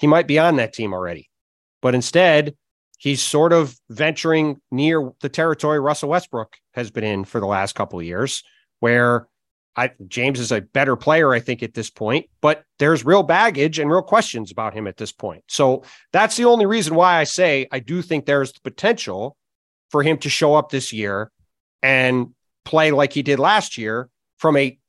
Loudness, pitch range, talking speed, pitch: -19 LUFS, 115-155 Hz, 195 wpm, 135 Hz